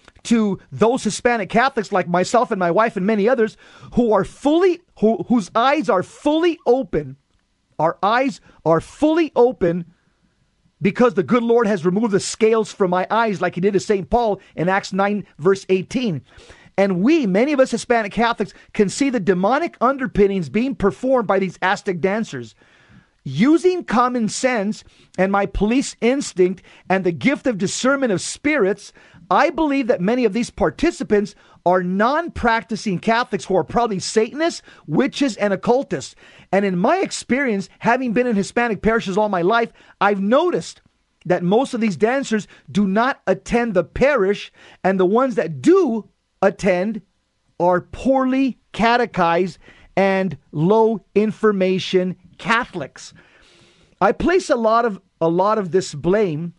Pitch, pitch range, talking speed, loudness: 210 Hz, 185-240 Hz, 155 wpm, -19 LUFS